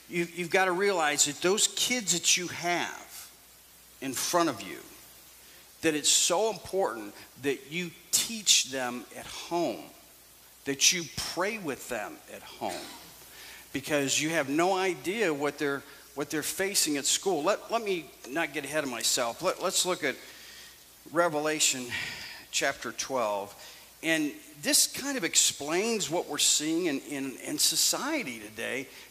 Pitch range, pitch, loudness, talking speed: 145-210 Hz, 175 Hz, -28 LUFS, 145 wpm